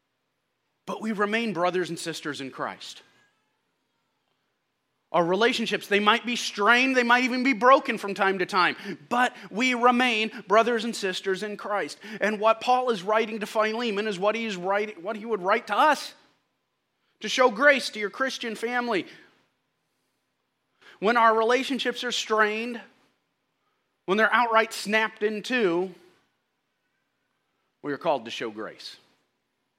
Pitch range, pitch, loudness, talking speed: 205-245 Hz, 225 Hz, -24 LUFS, 145 wpm